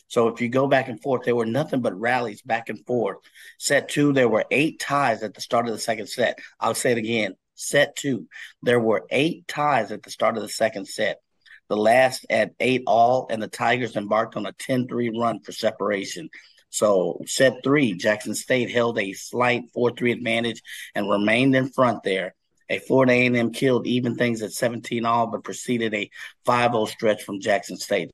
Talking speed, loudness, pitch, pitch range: 195 wpm, -23 LUFS, 120 Hz, 110-125 Hz